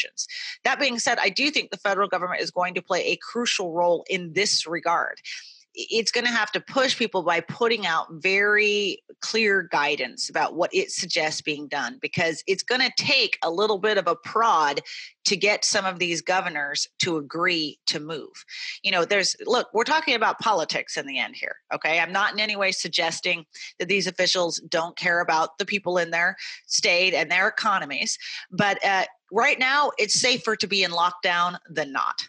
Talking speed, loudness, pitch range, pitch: 195 wpm, -23 LUFS, 170-235 Hz, 190 Hz